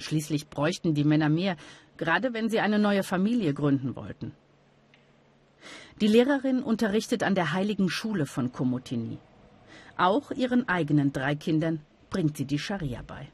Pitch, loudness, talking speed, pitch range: 160 Hz, -27 LUFS, 145 wpm, 145-210 Hz